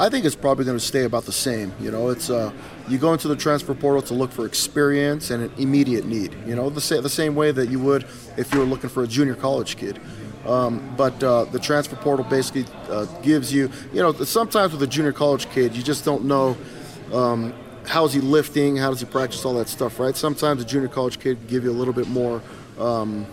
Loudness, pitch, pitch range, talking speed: -22 LUFS, 135 Hz, 125-145 Hz, 245 wpm